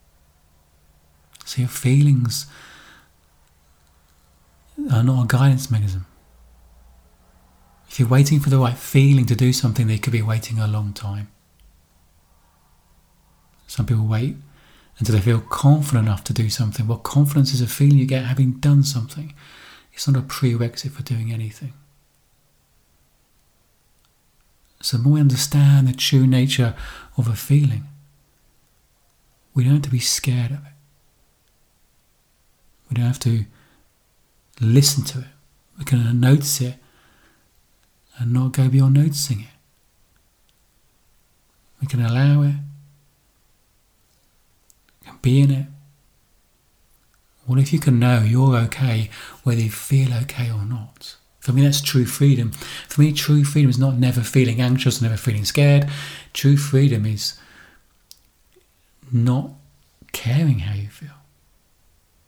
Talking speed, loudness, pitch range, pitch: 130 wpm, -19 LUFS, 105-140 Hz, 125 Hz